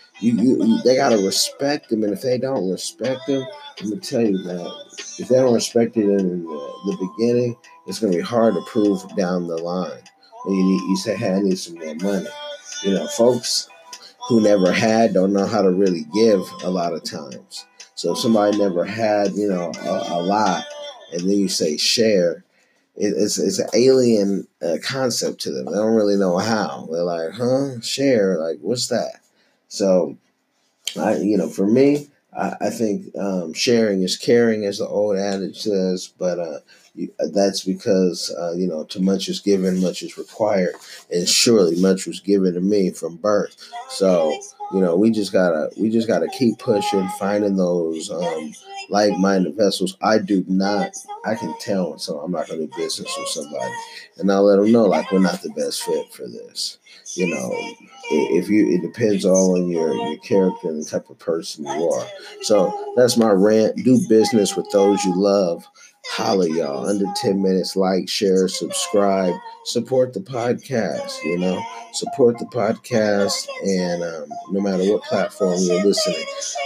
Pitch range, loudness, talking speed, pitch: 95-130 Hz, -20 LUFS, 185 wpm, 100 Hz